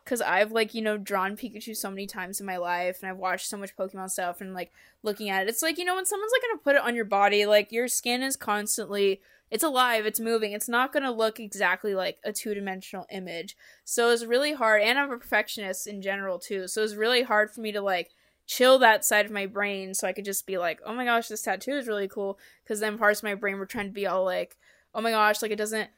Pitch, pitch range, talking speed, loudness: 210 Hz, 195-230 Hz, 265 wpm, -26 LUFS